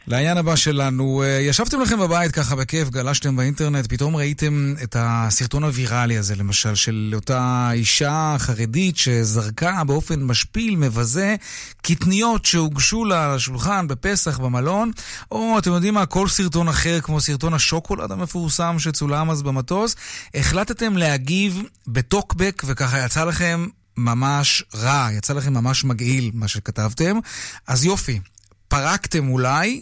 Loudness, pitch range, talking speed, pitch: -19 LUFS, 125-175 Hz, 130 wpm, 145 Hz